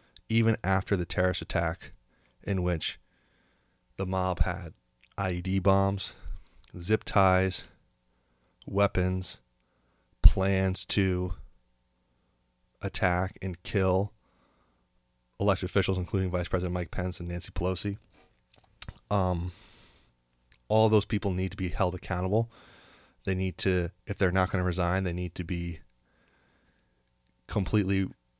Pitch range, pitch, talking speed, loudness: 80-95 Hz, 90 Hz, 110 wpm, -29 LUFS